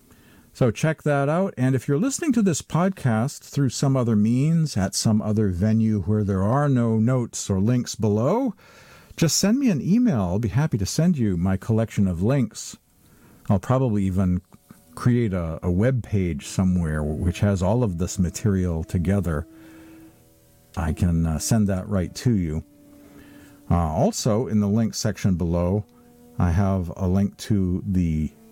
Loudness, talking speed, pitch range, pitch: -23 LUFS, 165 wpm, 90-125 Hz, 105 Hz